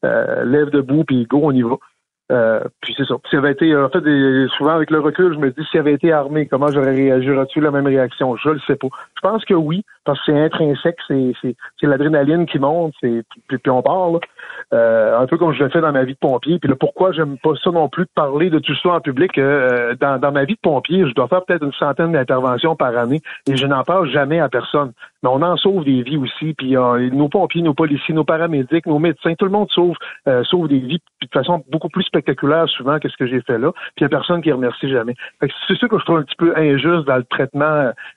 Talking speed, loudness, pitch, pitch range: 265 wpm, -16 LUFS, 150 Hz, 135-170 Hz